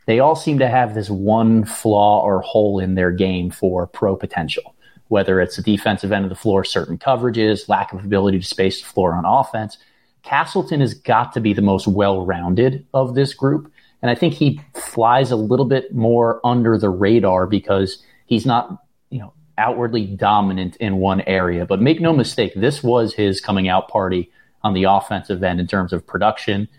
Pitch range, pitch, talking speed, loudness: 95-120 Hz, 105 Hz, 195 wpm, -18 LUFS